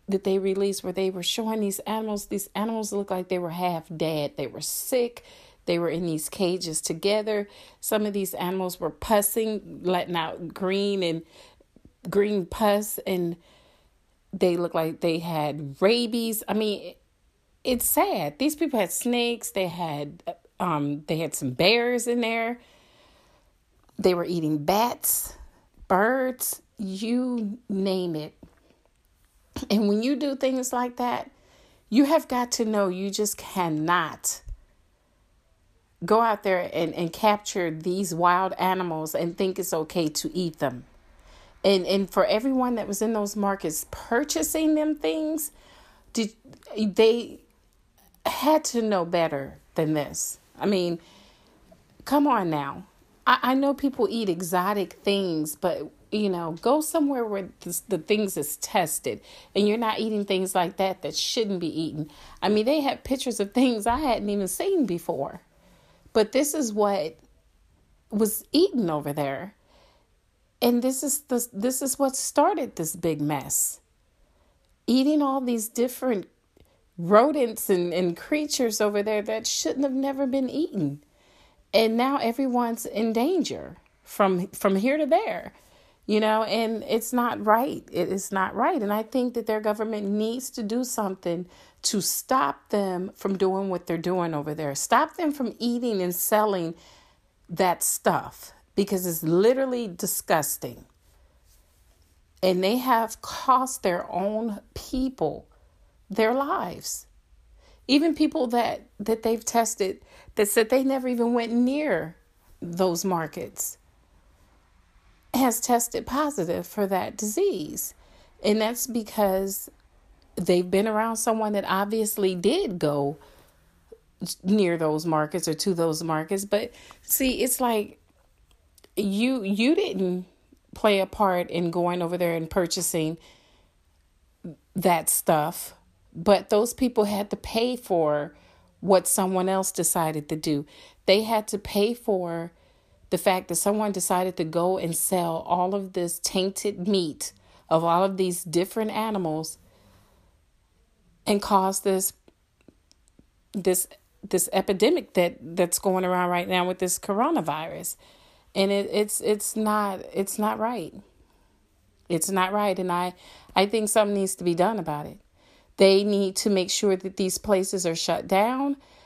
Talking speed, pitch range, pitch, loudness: 145 wpm, 170-230 Hz, 195 Hz, -25 LUFS